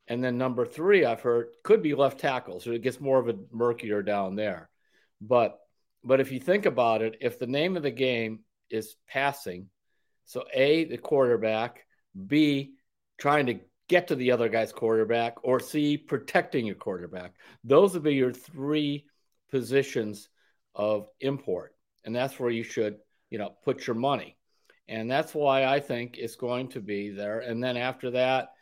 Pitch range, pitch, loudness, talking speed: 110-140 Hz, 125 Hz, -27 LUFS, 175 wpm